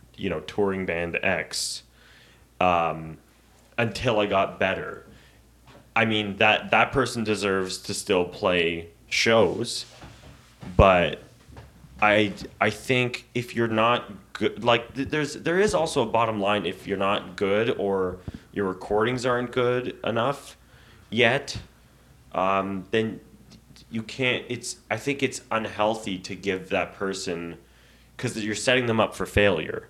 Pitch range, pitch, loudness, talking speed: 95-120 Hz, 110 Hz, -25 LUFS, 135 wpm